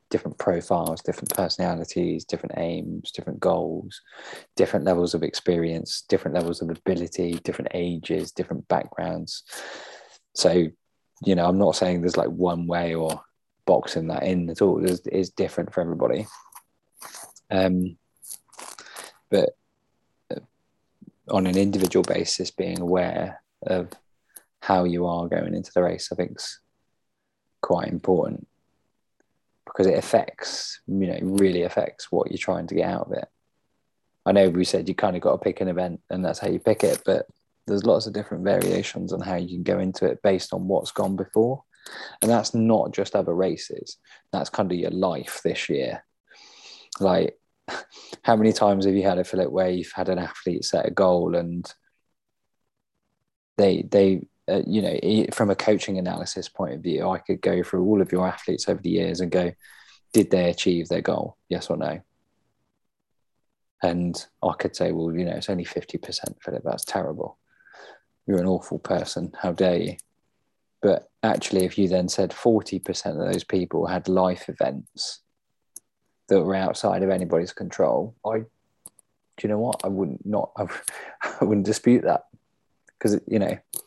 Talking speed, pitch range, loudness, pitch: 165 wpm, 85-95 Hz, -24 LUFS, 90 Hz